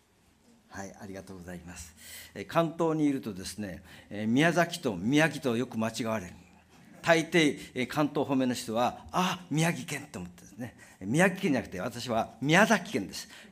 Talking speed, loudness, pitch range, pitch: 255 characters per minute, -29 LUFS, 95-155 Hz, 120 Hz